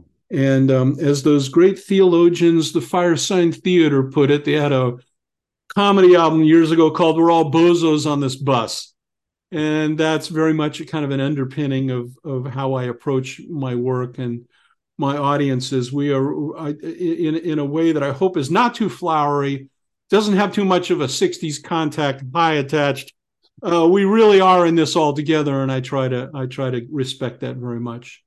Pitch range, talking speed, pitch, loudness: 135-165 Hz, 185 wpm, 150 Hz, -18 LUFS